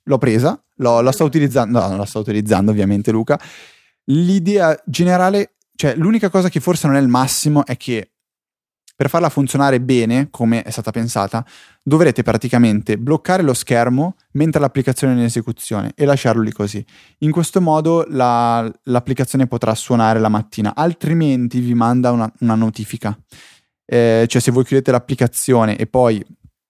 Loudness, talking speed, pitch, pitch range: -16 LUFS, 160 wpm, 125 Hz, 115-145 Hz